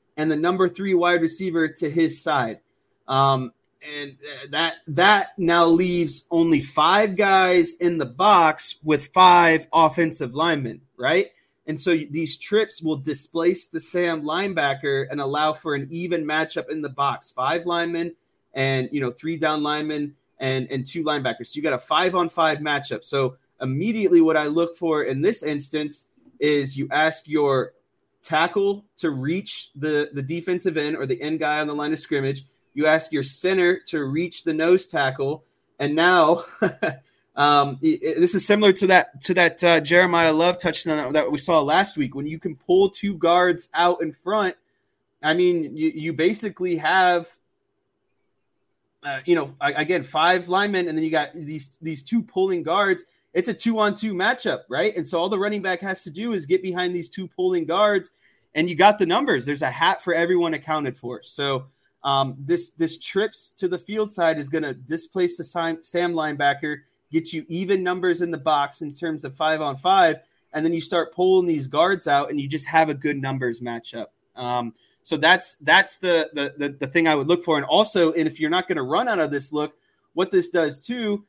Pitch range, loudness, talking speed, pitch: 150-180 Hz, -21 LUFS, 190 wpm, 165 Hz